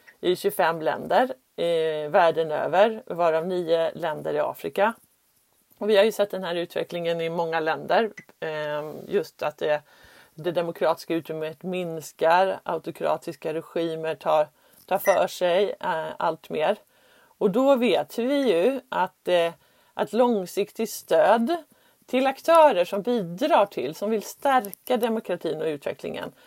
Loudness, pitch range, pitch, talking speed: -25 LUFS, 165-220 Hz, 180 Hz, 135 wpm